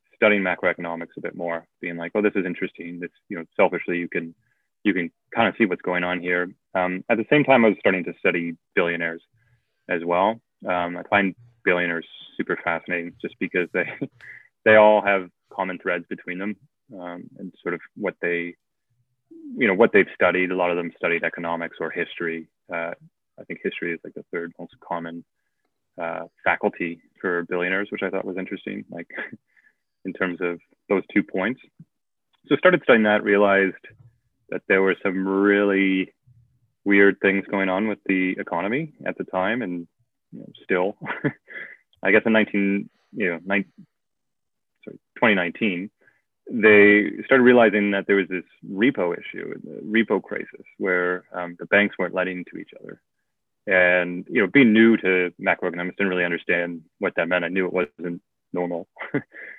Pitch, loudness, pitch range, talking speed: 95 Hz, -22 LUFS, 85-105 Hz, 175 wpm